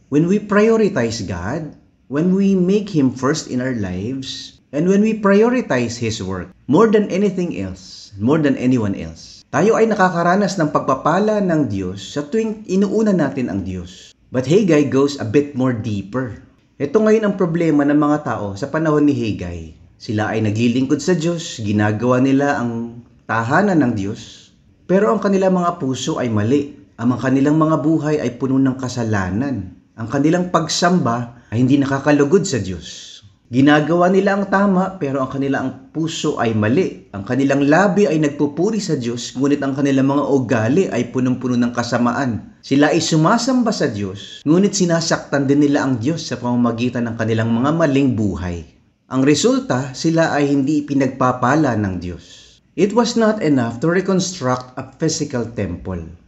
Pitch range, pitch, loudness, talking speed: 115-165 Hz, 135 Hz, -17 LUFS, 160 wpm